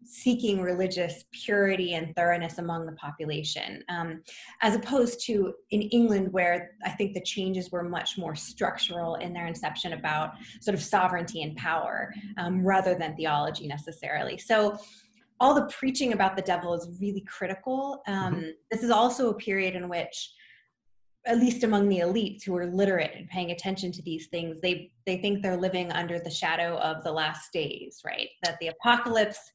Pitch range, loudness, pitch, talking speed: 170-210 Hz, -28 LUFS, 180 Hz, 175 wpm